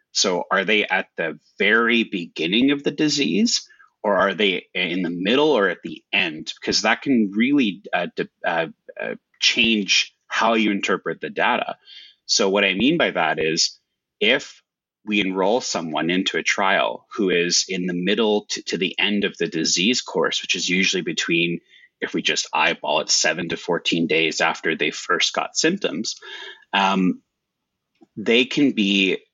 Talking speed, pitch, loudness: 170 wpm, 105 Hz, -20 LUFS